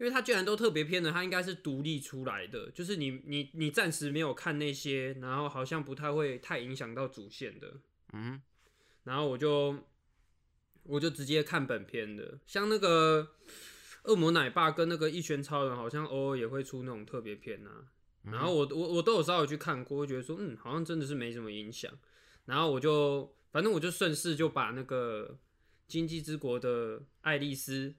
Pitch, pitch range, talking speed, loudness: 145 Hz, 130-160 Hz, 285 characters per minute, -33 LUFS